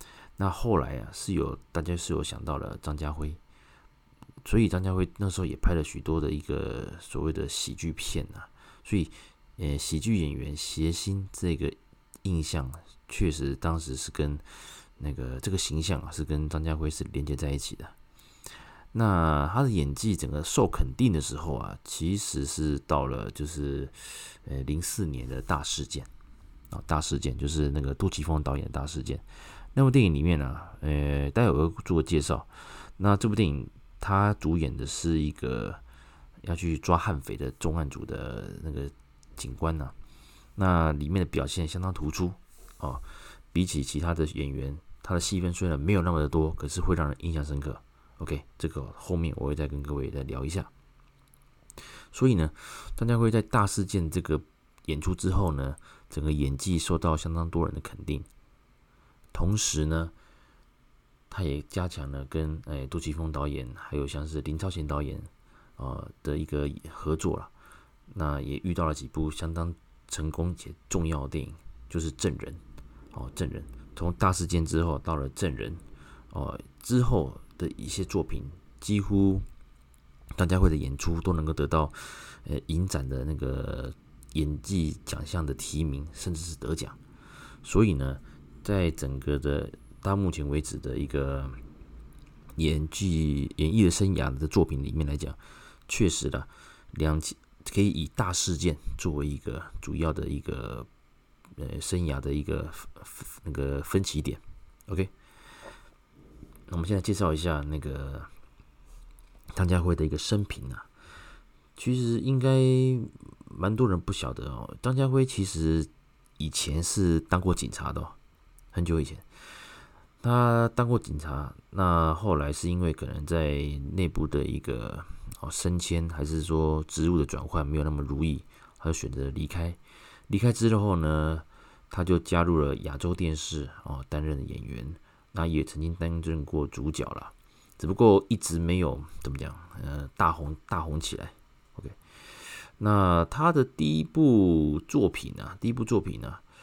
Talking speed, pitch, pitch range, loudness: 240 characters per minute, 80 Hz, 75-90 Hz, -29 LUFS